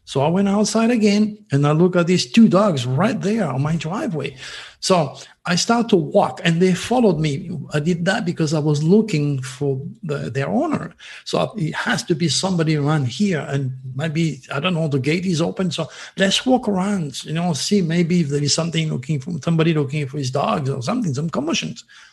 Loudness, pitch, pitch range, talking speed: -19 LUFS, 165 Hz, 150-195 Hz, 205 wpm